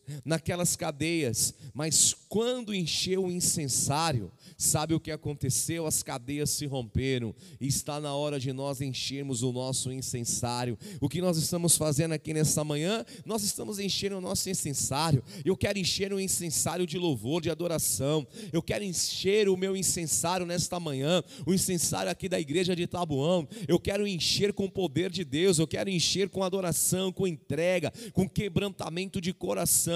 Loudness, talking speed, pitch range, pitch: -29 LUFS, 165 wpm, 145-185 Hz, 165 Hz